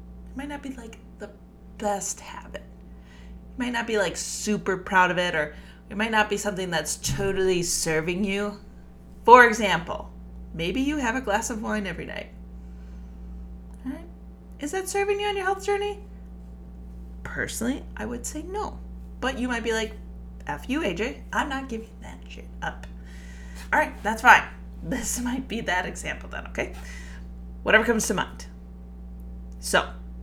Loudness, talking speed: -25 LUFS, 165 wpm